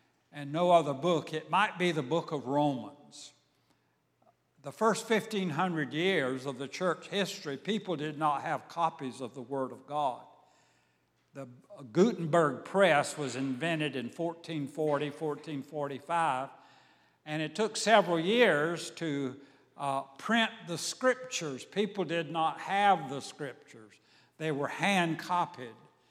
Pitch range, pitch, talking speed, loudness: 140-180 Hz, 160 Hz, 130 wpm, -31 LUFS